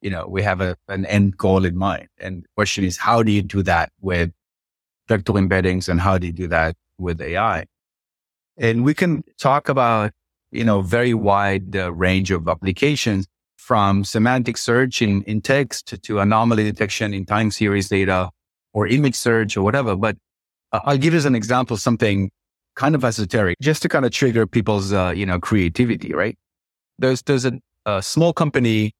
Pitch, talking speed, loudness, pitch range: 105 Hz, 185 wpm, -19 LUFS, 95-120 Hz